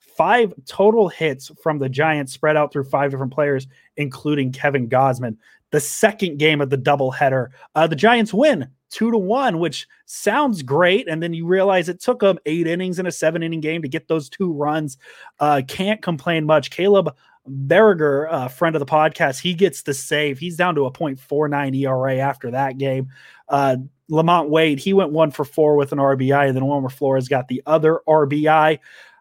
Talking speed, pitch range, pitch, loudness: 190 wpm, 140-175 Hz, 155 Hz, -19 LUFS